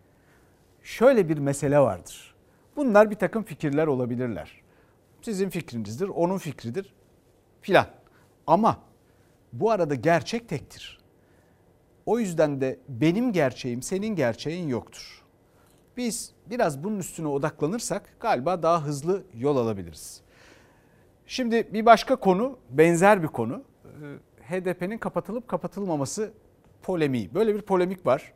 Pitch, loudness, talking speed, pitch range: 160 Hz, -25 LUFS, 110 wpm, 130-200 Hz